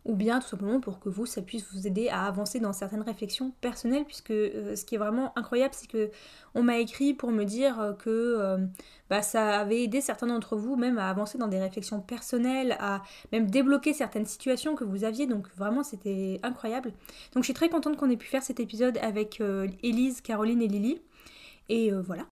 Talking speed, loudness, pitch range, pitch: 215 wpm, -30 LUFS, 210-255 Hz, 230 Hz